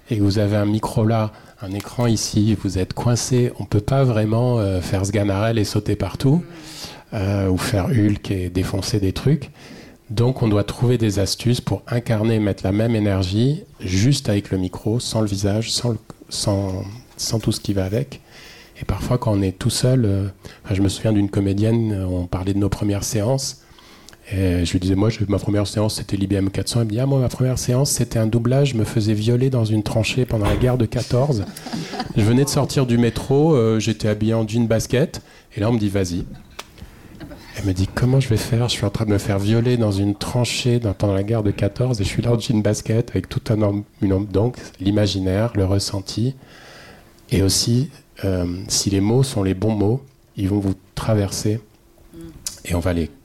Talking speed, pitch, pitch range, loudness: 210 wpm, 110 Hz, 100-120 Hz, -20 LUFS